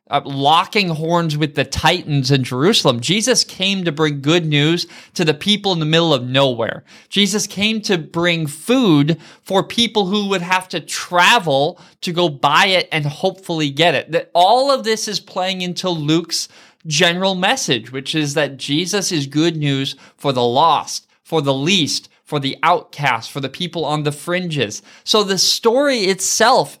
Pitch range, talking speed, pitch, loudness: 150-195 Hz, 170 wpm, 170 Hz, -16 LUFS